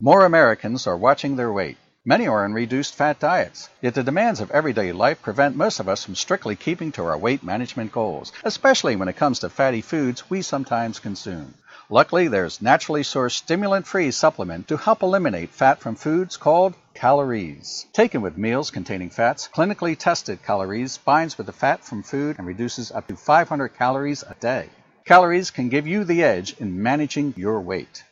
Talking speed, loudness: 180 wpm, -21 LUFS